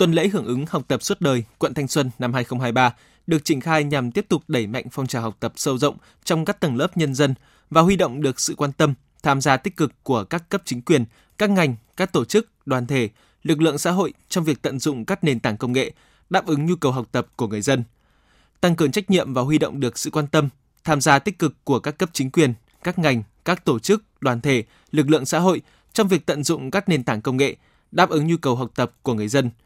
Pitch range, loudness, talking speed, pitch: 125-170 Hz, -21 LUFS, 255 wpm, 145 Hz